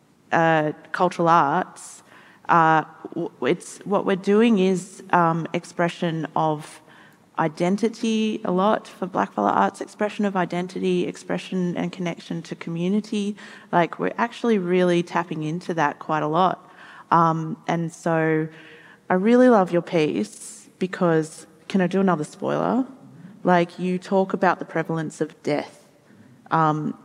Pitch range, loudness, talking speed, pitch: 160-195 Hz, -22 LUFS, 130 wpm, 175 Hz